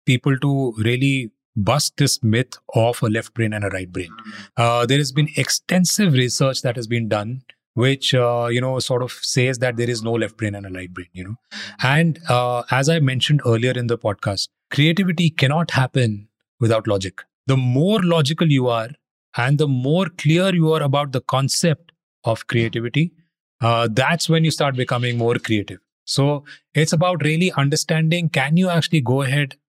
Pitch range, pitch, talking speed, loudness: 115-155 Hz, 130 Hz, 185 wpm, -19 LUFS